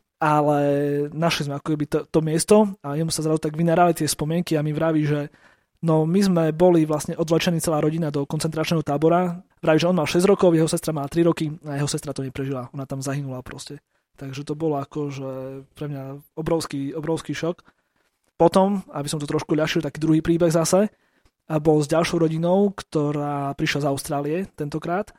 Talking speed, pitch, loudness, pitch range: 195 wpm, 155 Hz, -22 LUFS, 145-165 Hz